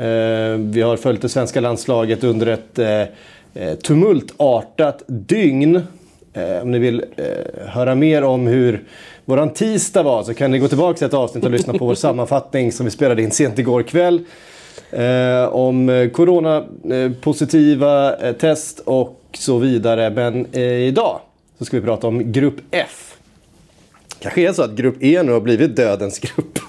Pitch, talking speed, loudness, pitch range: 125 Hz, 150 wpm, -17 LUFS, 120-145 Hz